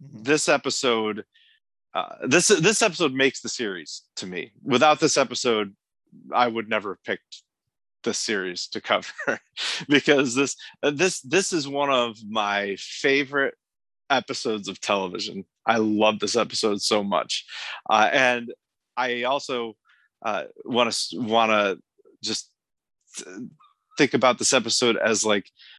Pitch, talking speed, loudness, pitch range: 125 Hz, 135 wpm, -23 LUFS, 110-150 Hz